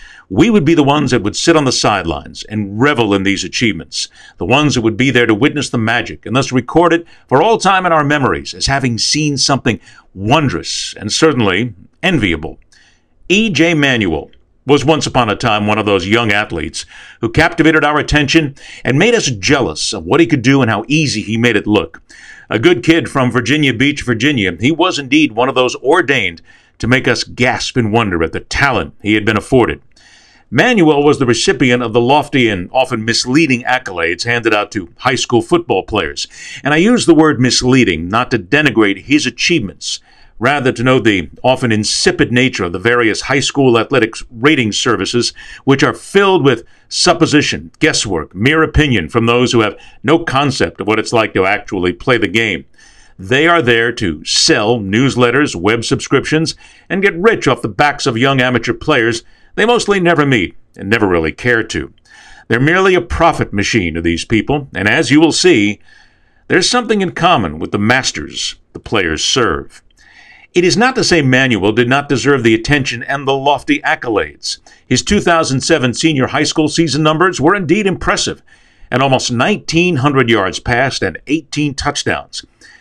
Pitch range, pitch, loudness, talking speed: 115-155 Hz, 135 Hz, -13 LUFS, 185 wpm